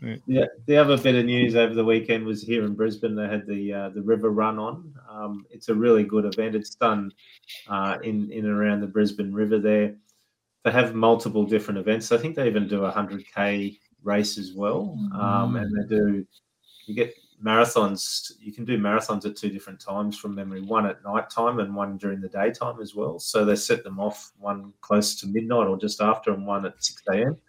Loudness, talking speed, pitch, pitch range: -24 LUFS, 210 wpm, 105 Hz, 100-115 Hz